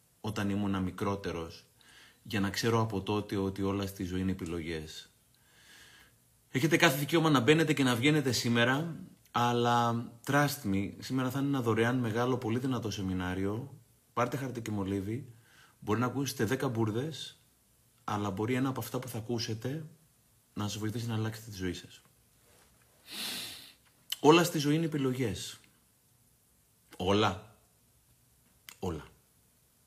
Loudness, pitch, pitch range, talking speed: -31 LUFS, 120 Hz, 100-130 Hz, 135 wpm